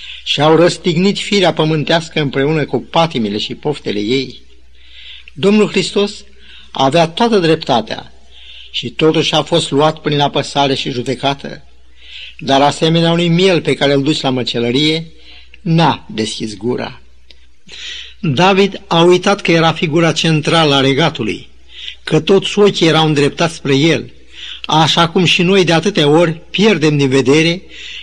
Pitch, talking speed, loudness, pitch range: 155 Hz, 135 wpm, -13 LUFS, 135-170 Hz